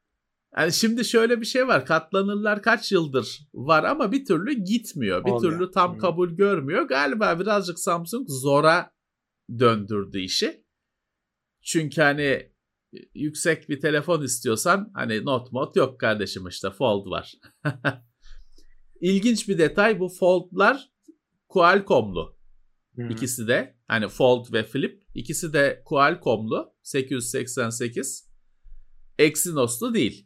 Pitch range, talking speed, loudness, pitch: 130-200 Hz, 115 wpm, -23 LUFS, 160 Hz